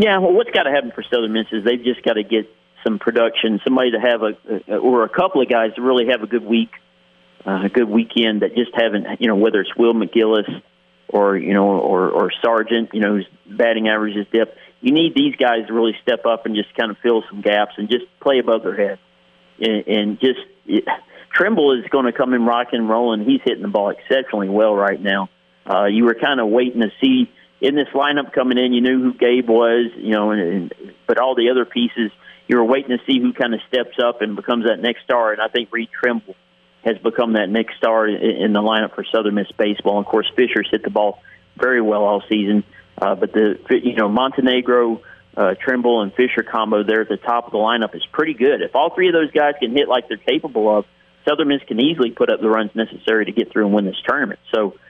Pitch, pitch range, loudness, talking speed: 115 Hz, 105-125 Hz, -18 LUFS, 235 wpm